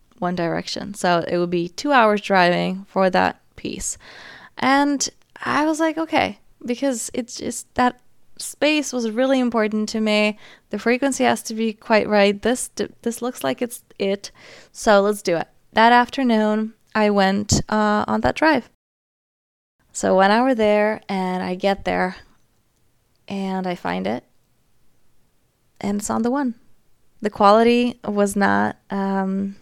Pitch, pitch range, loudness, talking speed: 210 Hz, 190-245 Hz, -20 LUFS, 150 wpm